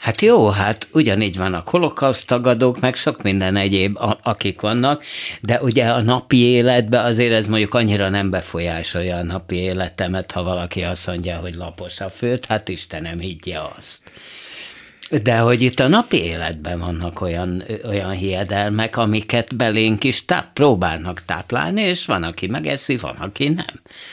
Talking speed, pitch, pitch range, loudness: 155 wpm, 105 Hz, 90-125 Hz, -19 LUFS